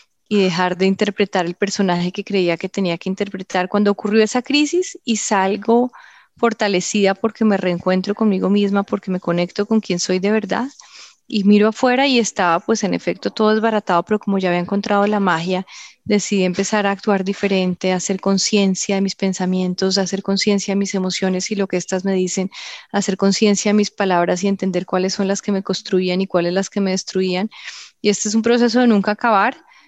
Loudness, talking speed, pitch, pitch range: -18 LUFS, 200 wpm, 195 Hz, 185-210 Hz